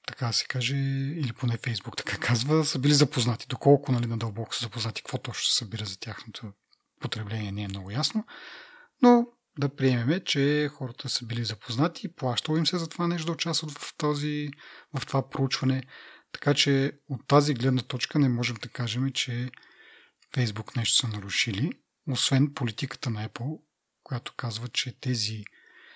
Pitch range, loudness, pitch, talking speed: 120-150 Hz, -27 LUFS, 130 Hz, 165 wpm